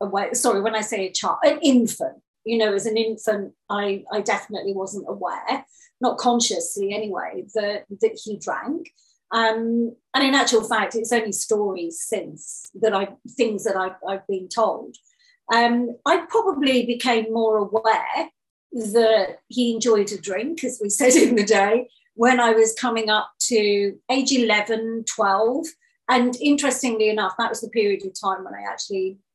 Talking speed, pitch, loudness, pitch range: 165 wpm, 225 Hz, -21 LUFS, 205-245 Hz